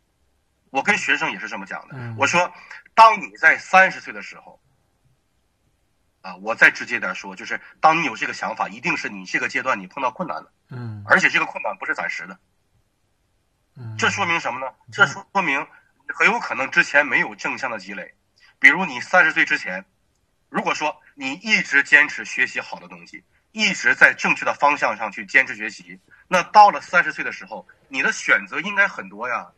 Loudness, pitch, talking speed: -19 LUFS, 155 Hz, 280 characters per minute